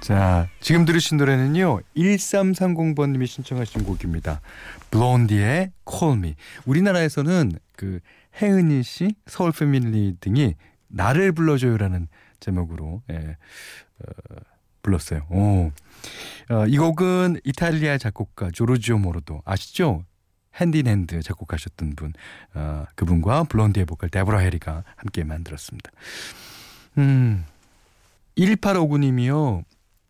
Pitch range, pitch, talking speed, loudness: 90-150 Hz, 110 Hz, 245 characters per minute, -22 LUFS